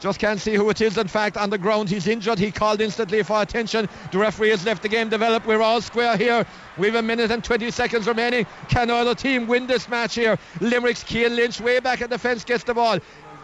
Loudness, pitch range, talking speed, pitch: -21 LUFS, 215-235 Hz, 245 wpm, 225 Hz